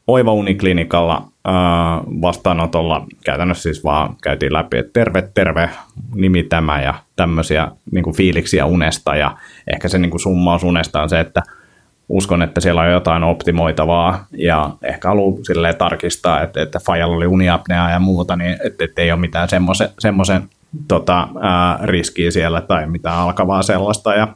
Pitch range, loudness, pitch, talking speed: 85-95 Hz, -16 LUFS, 85 Hz, 155 wpm